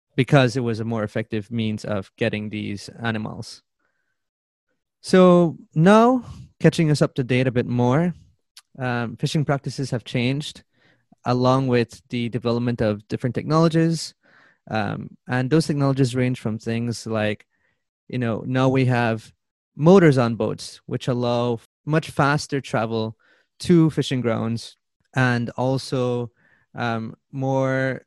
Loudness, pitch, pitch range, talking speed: -22 LUFS, 125 Hz, 115-140 Hz, 130 wpm